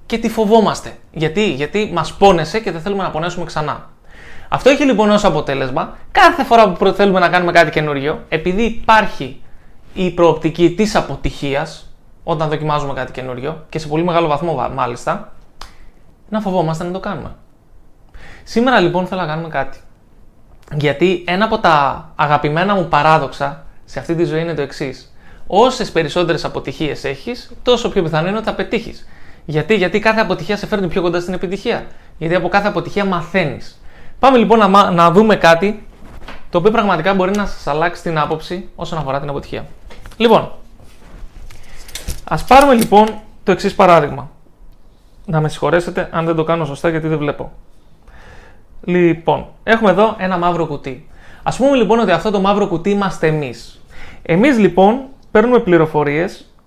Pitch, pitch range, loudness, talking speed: 175 Hz, 155-205 Hz, -15 LUFS, 160 wpm